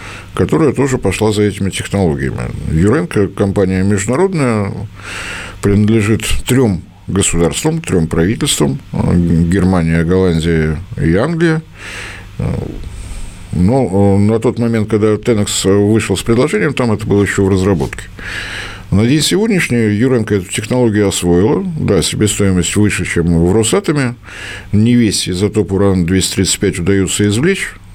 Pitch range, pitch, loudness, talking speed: 95-115 Hz, 100 Hz, -13 LUFS, 110 wpm